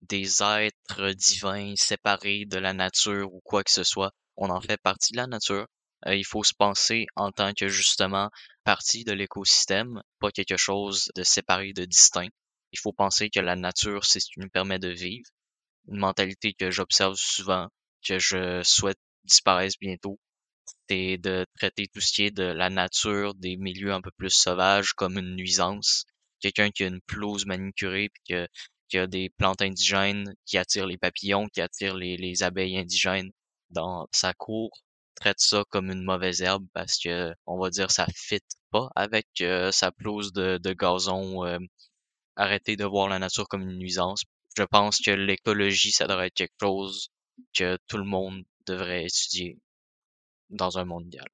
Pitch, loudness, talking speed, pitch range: 95 Hz, -25 LUFS, 180 wpm, 95-100 Hz